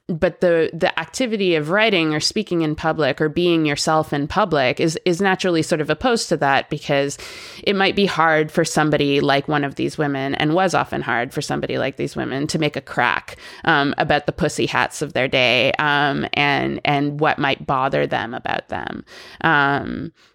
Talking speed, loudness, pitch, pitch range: 195 wpm, -19 LUFS, 155 Hz, 145-175 Hz